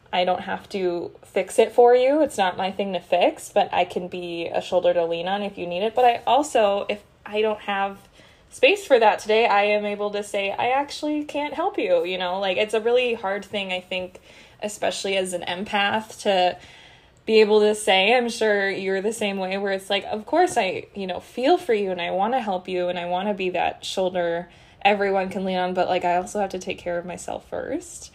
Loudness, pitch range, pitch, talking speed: -23 LUFS, 180-220 Hz, 200 Hz, 235 wpm